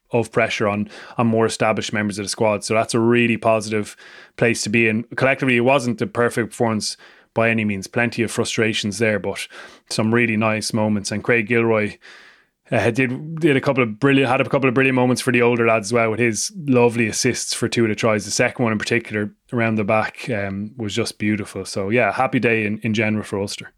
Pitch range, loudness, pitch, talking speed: 105-120 Hz, -19 LUFS, 115 Hz, 225 wpm